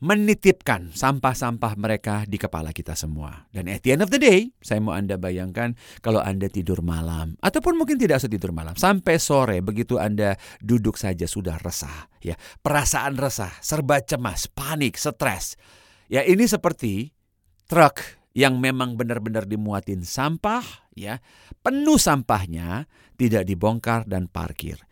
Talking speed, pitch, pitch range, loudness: 140 wpm, 110 Hz, 95-140 Hz, -23 LUFS